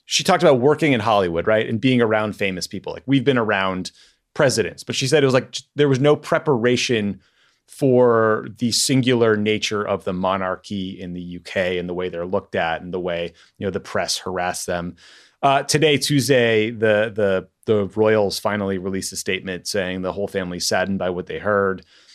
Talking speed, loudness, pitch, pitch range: 195 wpm, -20 LUFS, 110 Hz, 95-125 Hz